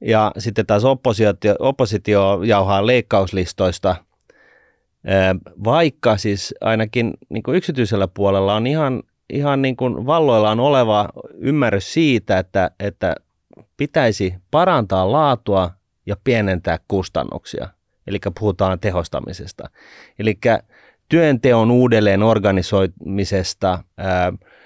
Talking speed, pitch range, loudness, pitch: 90 wpm, 95-120 Hz, -18 LUFS, 105 Hz